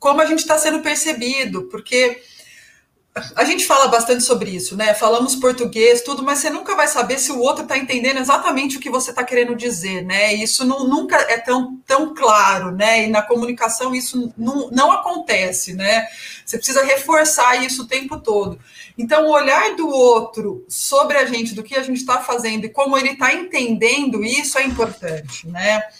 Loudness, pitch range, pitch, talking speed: -16 LUFS, 225-275 Hz, 255 Hz, 185 wpm